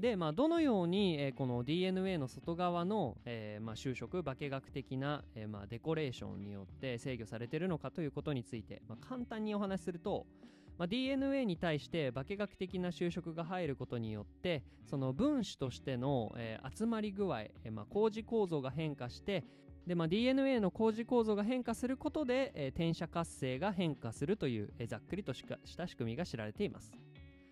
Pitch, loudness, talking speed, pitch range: 160 Hz, -38 LUFS, 385 characters per minute, 125-200 Hz